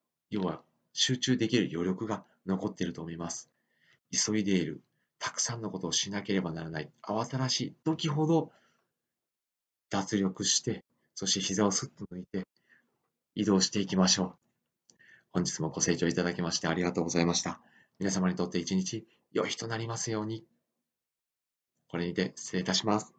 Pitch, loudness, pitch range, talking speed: 95 Hz, -31 LUFS, 85-110 Hz, 335 characters per minute